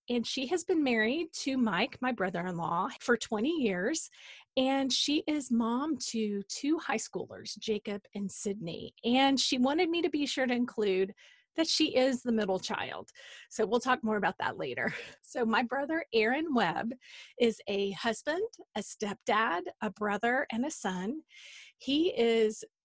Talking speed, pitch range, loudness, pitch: 165 wpm, 210-285 Hz, -31 LUFS, 240 Hz